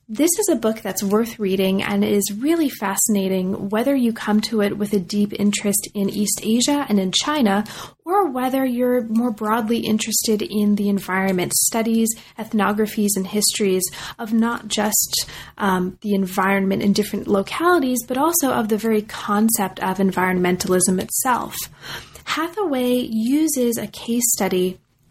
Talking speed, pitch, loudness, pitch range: 150 wpm, 210 Hz, -20 LUFS, 195-235 Hz